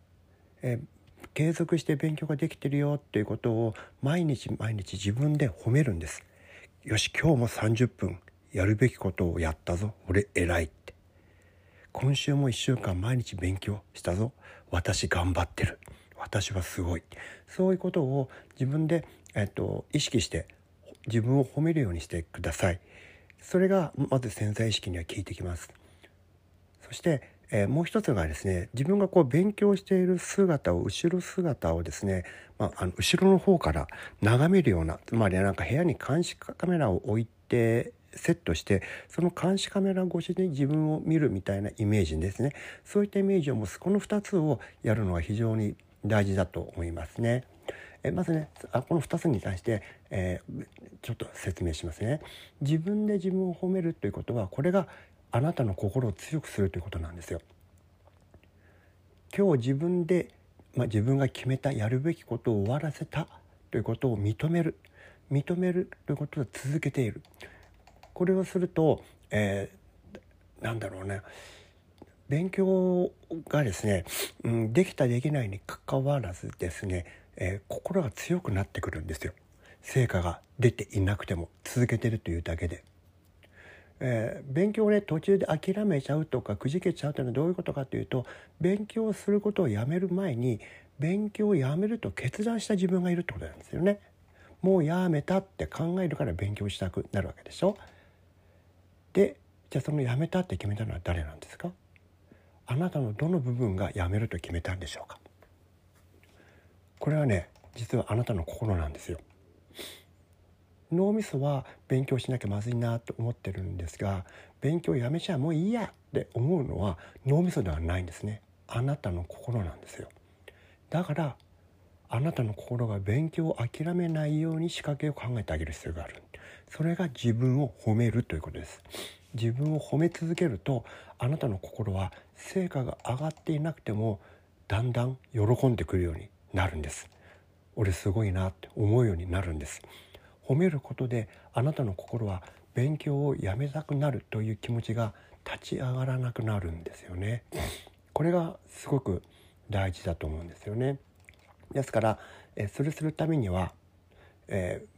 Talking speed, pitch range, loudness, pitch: 325 characters per minute, 95-150 Hz, -30 LUFS, 110 Hz